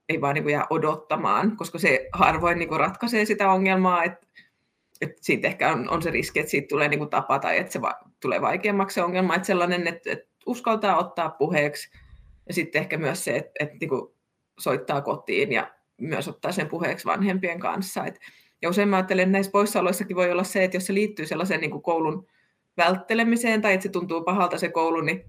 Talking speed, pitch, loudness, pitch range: 175 wpm, 180 Hz, -24 LUFS, 170-195 Hz